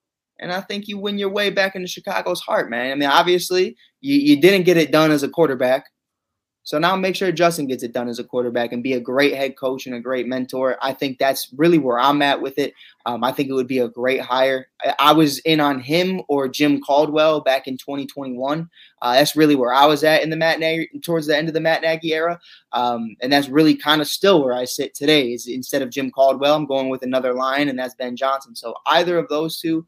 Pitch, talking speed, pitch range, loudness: 140 Hz, 250 wpm, 130-160 Hz, -19 LUFS